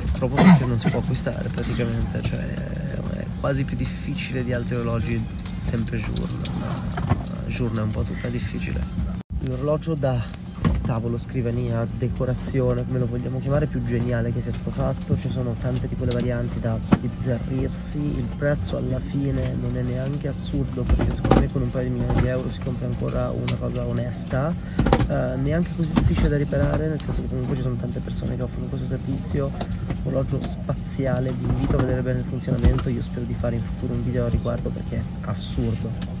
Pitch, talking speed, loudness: 120 Hz, 185 wpm, -24 LUFS